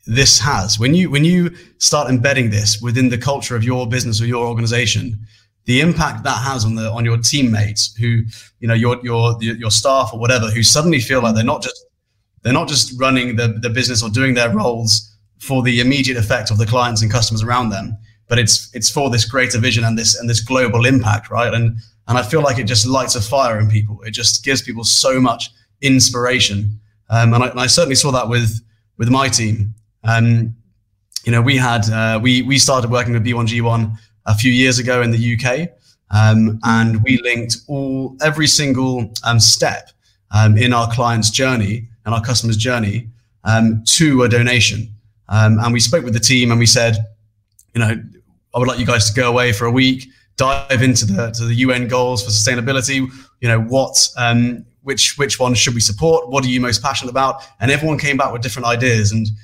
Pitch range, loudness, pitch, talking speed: 110-130 Hz, -15 LUFS, 120 Hz, 210 wpm